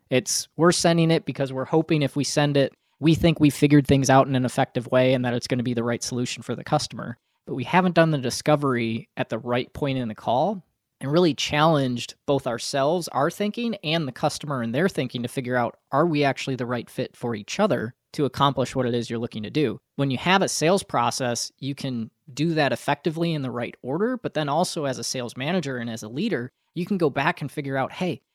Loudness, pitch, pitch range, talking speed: -24 LUFS, 140 Hz, 125-155 Hz, 240 wpm